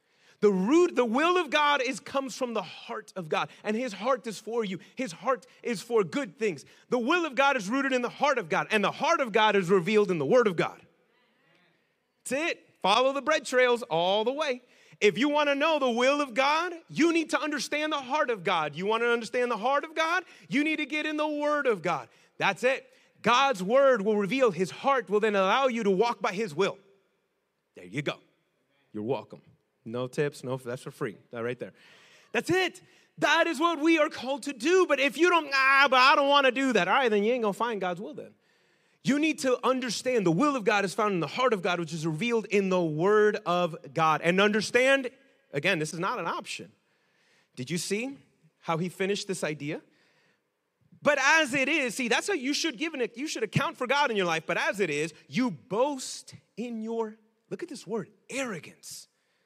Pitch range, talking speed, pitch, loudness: 195-285 Hz, 225 wpm, 240 Hz, -27 LUFS